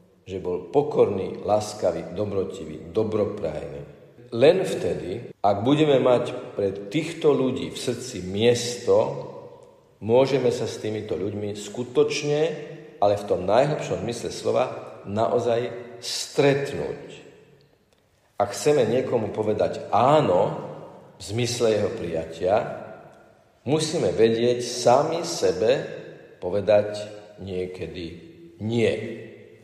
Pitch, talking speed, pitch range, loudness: 120 Hz, 95 wpm, 105-150 Hz, -24 LUFS